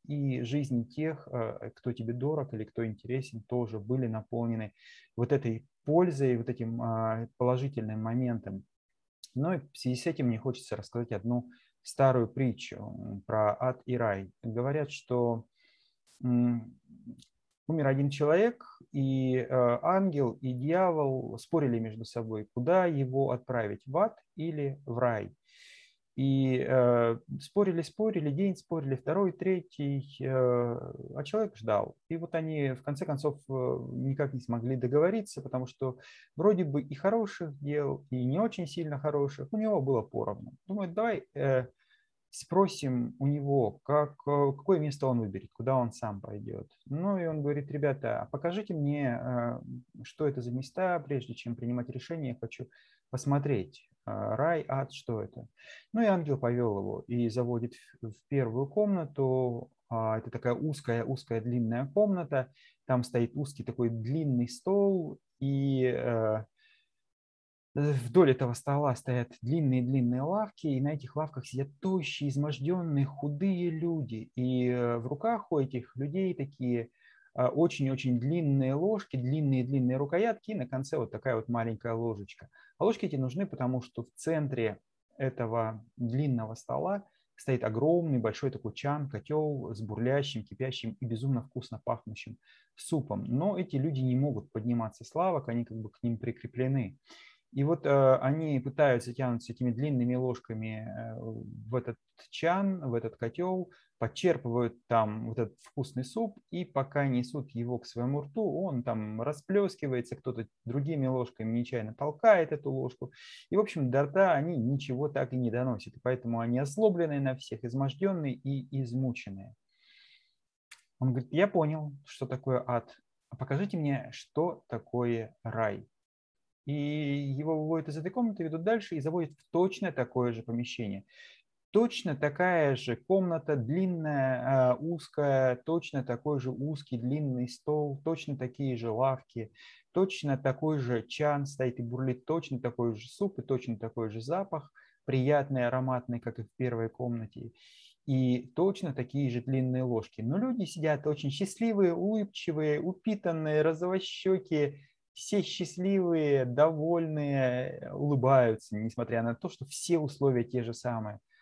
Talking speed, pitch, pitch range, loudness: 140 wpm, 135 Hz, 120-155 Hz, -32 LUFS